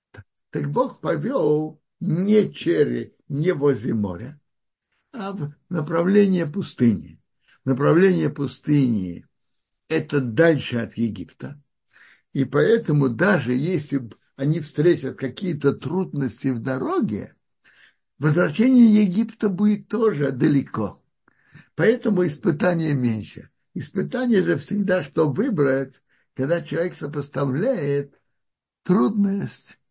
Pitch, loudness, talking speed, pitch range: 150 Hz, -22 LUFS, 90 wpm, 135-185 Hz